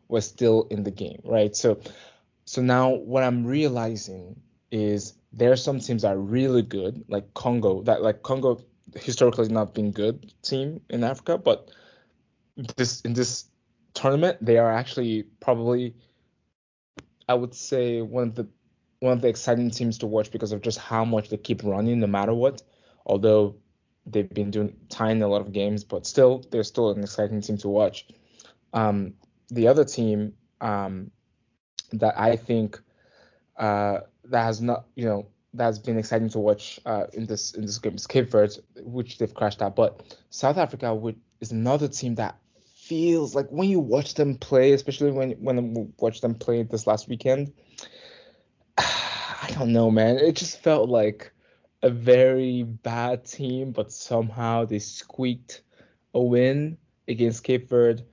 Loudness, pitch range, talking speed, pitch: -24 LUFS, 110-130 Hz, 170 wpm, 115 Hz